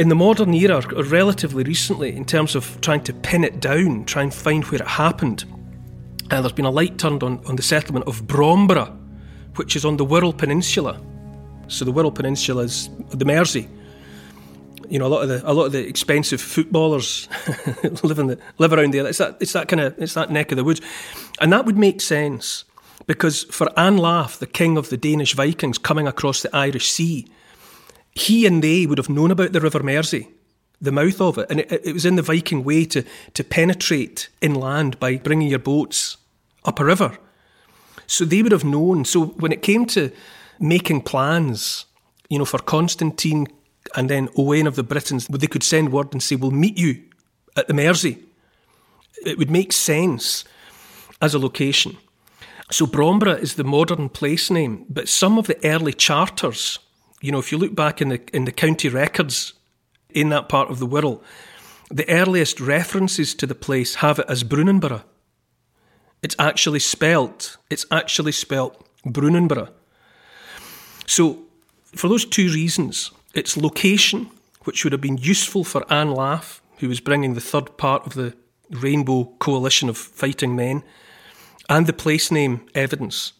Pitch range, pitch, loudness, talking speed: 135-165 Hz, 150 Hz, -19 LUFS, 180 wpm